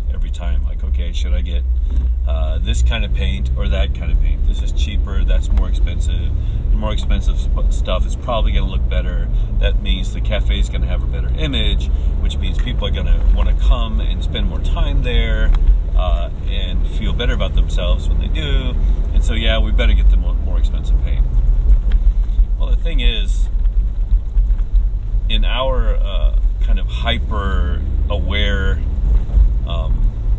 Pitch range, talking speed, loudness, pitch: 65-75 Hz, 170 wpm, -19 LUFS, 70 Hz